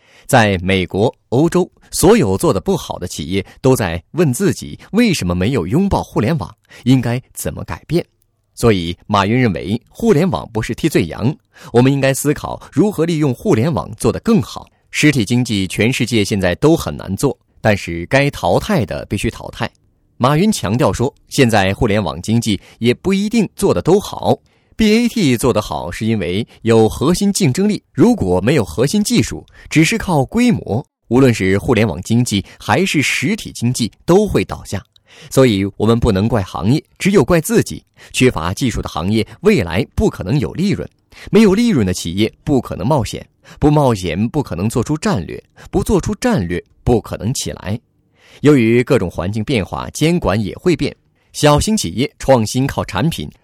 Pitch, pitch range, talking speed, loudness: 115 Hz, 100-150 Hz, 265 characters per minute, -16 LUFS